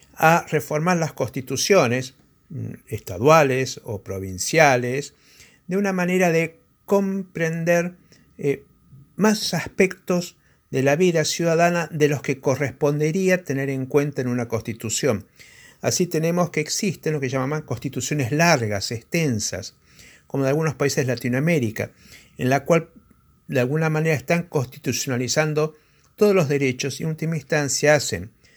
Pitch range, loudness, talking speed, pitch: 130-165 Hz, -22 LUFS, 130 wpm, 150 Hz